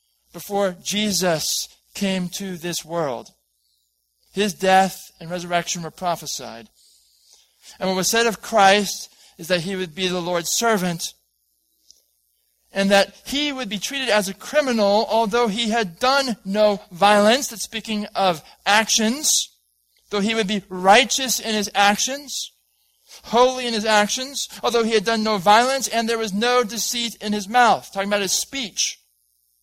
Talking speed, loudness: 150 wpm, -20 LUFS